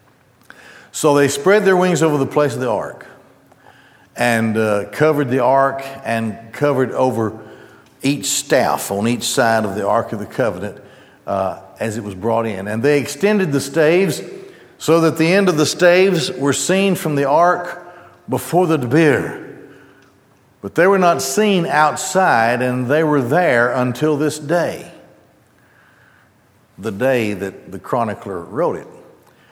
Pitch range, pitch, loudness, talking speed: 120-175 Hz, 140 Hz, -17 LUFS, 155 wpm